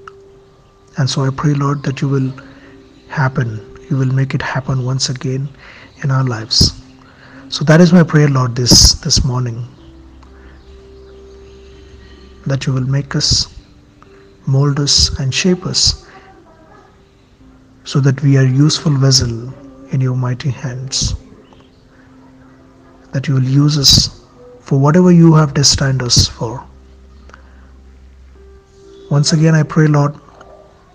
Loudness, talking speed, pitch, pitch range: -13 LUFS, 125 wpm, 130 Hz, 105-140 Hz